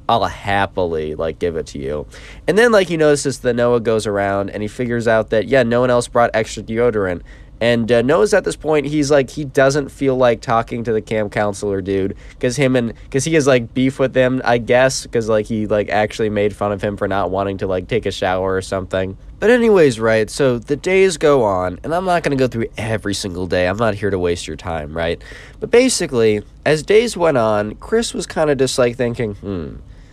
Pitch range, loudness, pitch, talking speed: 100-135 Hz, -17 LUFS, 115 Hz, 225 wpm